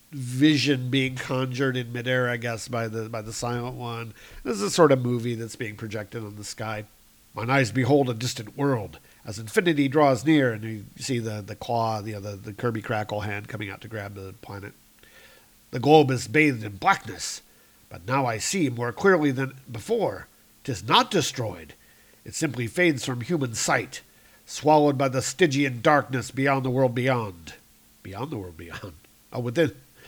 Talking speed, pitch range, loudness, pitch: 180 wpm, 110-135 Hz, -25 LUFS, 120 Hz